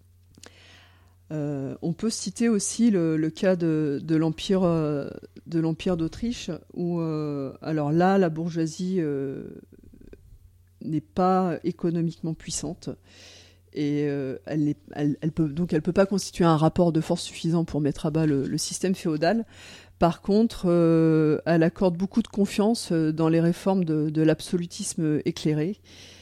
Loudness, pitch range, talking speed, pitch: -25 LUFS, 145-180 Hz, 145 wpm, 160 Hz